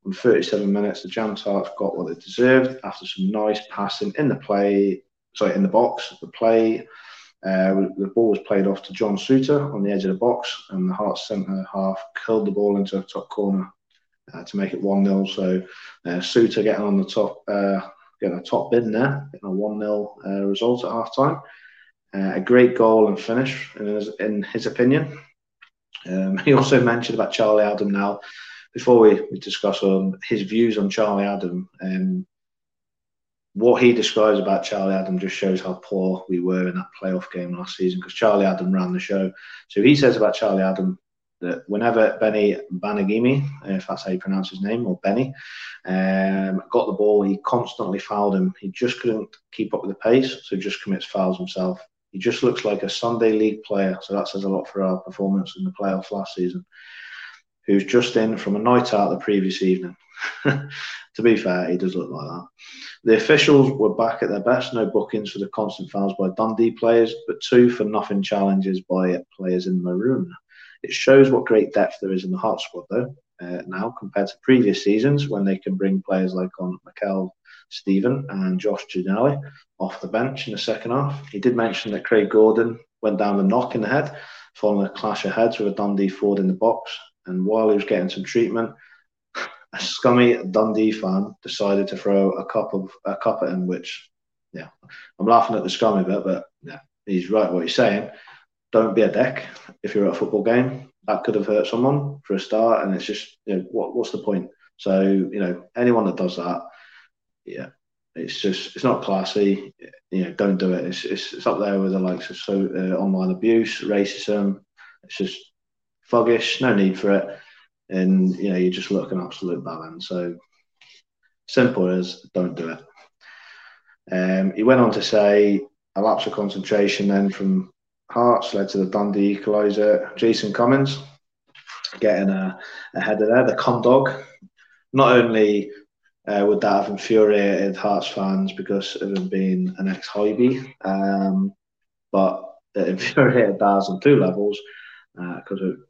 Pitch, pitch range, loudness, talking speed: 100 Hz, 95-115 Hz, -21 LUFS, 190 wpm